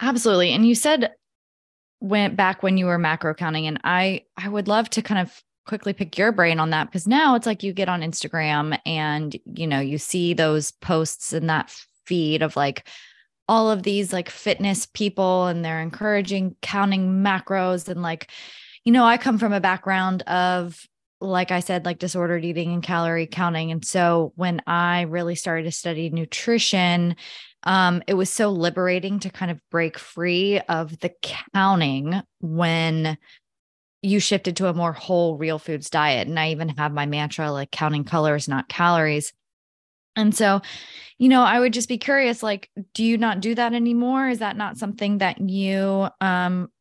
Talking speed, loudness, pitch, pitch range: 180 wpm, -22 LUFS, 180 Hz, 165-200 Hz